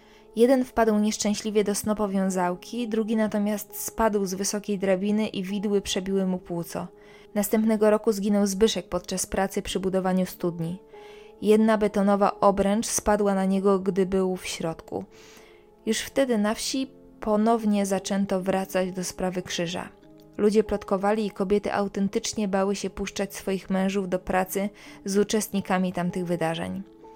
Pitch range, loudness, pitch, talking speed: 190-215 Hz, -25 LUFS, 200 Hz, 135 wpm